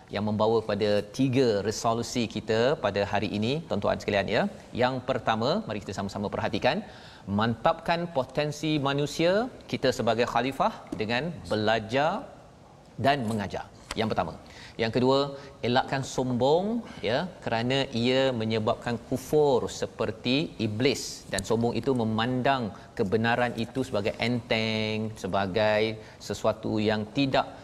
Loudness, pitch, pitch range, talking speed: -27 LUFS, 120 Hz, 110-135 Hz, 115 wpm